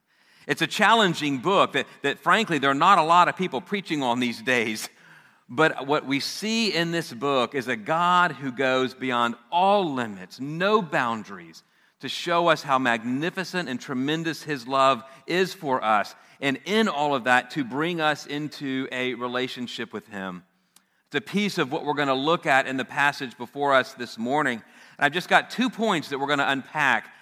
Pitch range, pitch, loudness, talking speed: 130-170 Hz, 140 Hz, -24 LUFS, 195 wpm